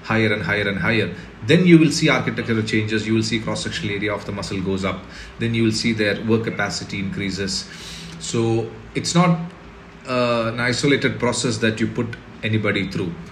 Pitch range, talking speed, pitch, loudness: 105-120 Hz, 185 wpm, 110 Hz, -20 LUFS